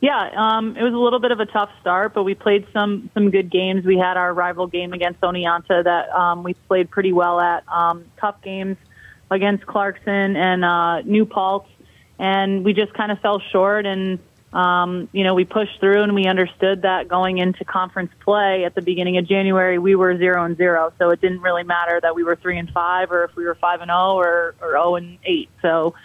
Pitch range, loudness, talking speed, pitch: 175-200 Hz, -19 LUFS, 220 wpm, 185 Hz